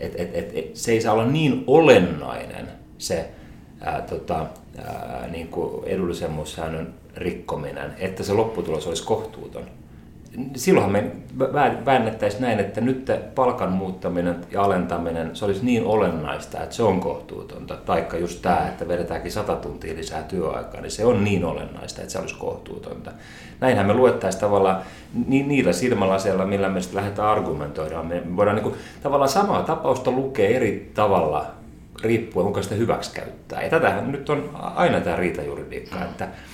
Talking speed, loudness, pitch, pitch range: 155 wpm, -23 LUFS, 95 Hz, 85-110 Hz